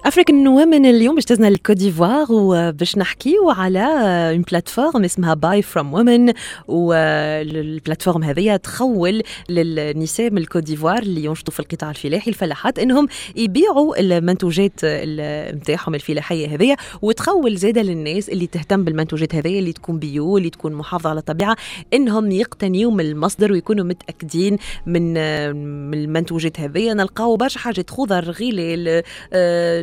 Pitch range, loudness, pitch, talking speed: 160-220 Hz, -17 LUFS, 180 Hz, 125 wpm